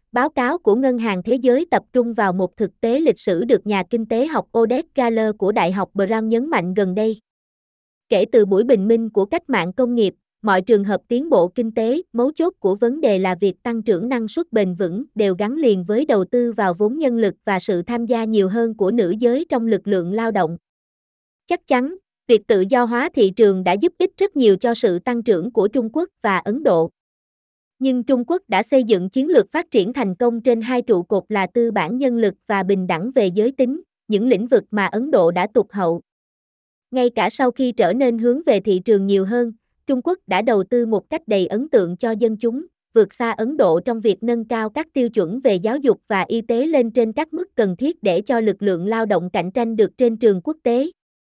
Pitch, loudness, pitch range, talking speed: 230 Hz, -19 LUFS, 200-255 Hz, 240 wpm